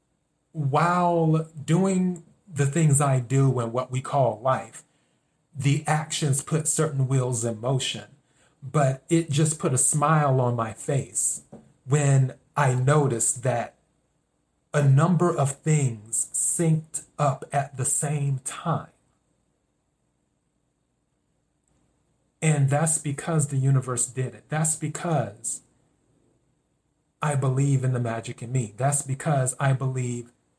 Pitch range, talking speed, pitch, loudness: 130-155 Hz, 120 wpm, 140 Hz, -24 LUFS